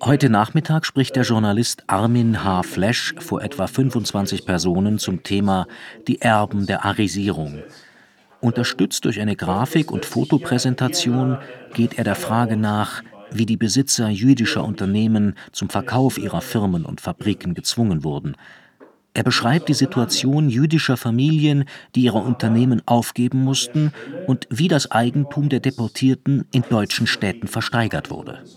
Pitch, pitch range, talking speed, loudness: 120 Hz, 105-130 Hz, 135 wpm, -20 LUFS